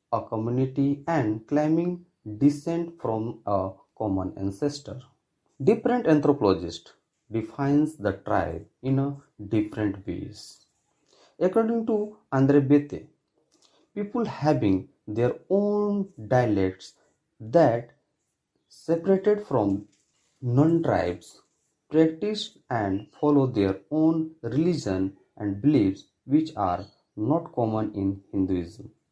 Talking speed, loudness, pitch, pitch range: 95 wpm, -26 LUFS, 135 Hz, 105-160 Hz